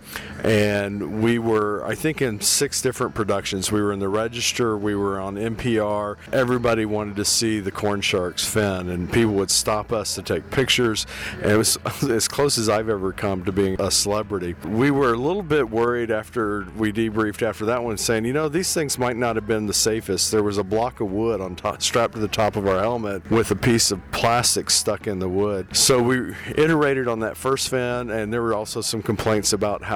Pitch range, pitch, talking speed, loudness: 100-120 Hz, 110 Hz, 220 wpm, -21 LUFS